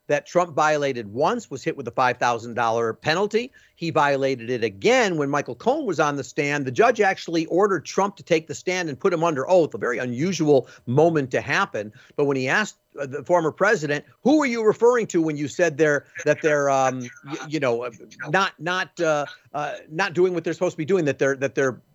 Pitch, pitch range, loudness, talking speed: 155 Hz, 135-180 Hz, -22 LUFS, 220 wpm